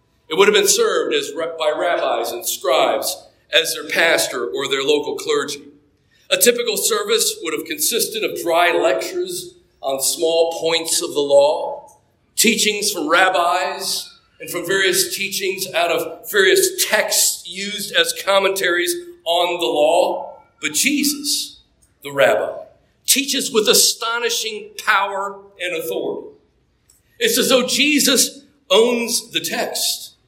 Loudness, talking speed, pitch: -17 LUFS, 130 wpm, 270 Hz